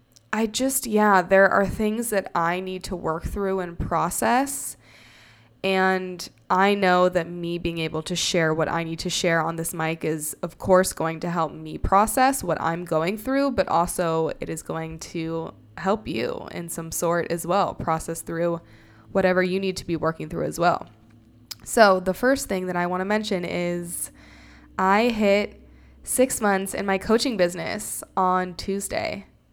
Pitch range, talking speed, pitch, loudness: 160-195 Hz, 175 wpm, 175 Hz, -24 LUFS